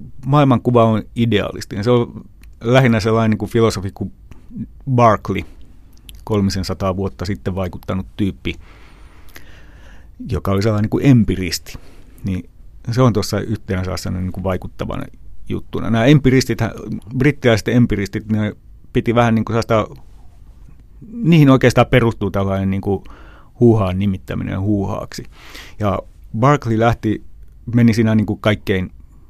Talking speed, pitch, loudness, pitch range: 115 wpm, 105 Hz, -17 LUFS, 95-115 Hz